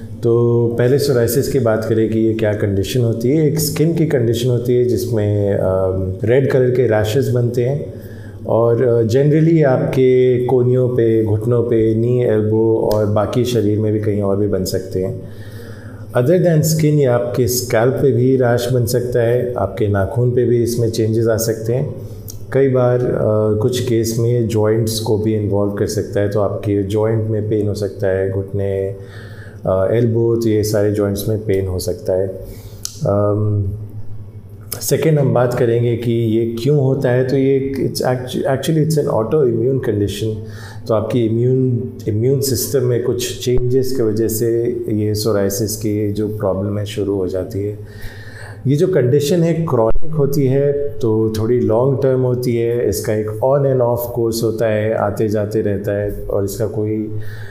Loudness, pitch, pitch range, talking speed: -16 LUFS, 115 Hz, 105-125 Hz, 175 wpm